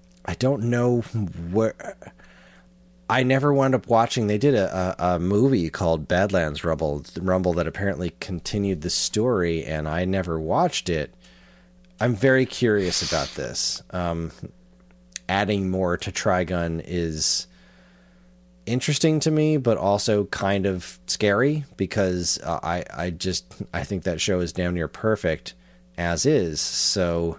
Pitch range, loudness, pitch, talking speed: 80-110 Hz, -23 LUFS, 90 Hz, 140 wpm